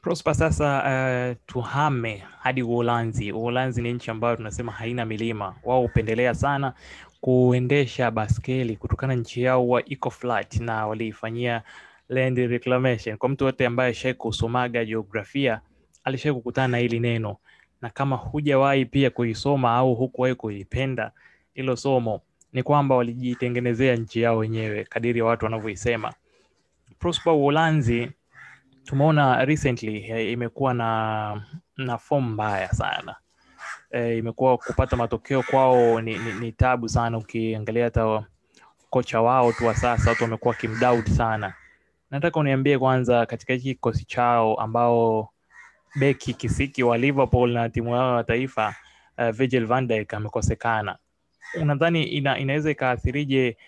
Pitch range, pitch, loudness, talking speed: 115-130 Hz, 120 Hz, -24 LUFS, 115 wpm